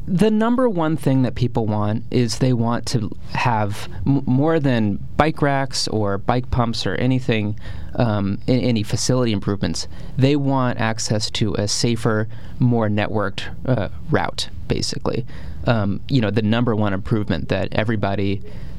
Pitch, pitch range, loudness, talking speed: 115 Hz, 105-130 Hz, -21 LUFS, 150 wpm